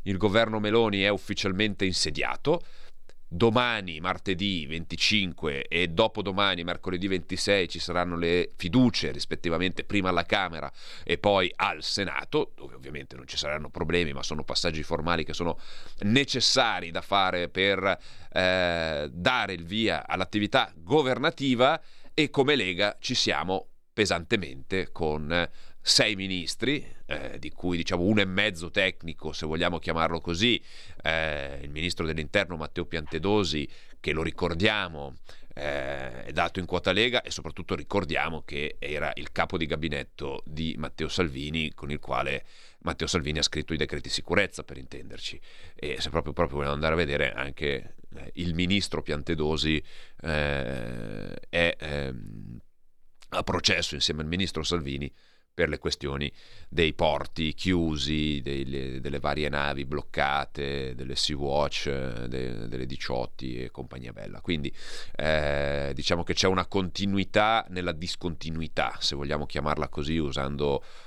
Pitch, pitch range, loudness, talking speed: 85 Hz, 75-95 Hz, -28 LUFS, 135 wpm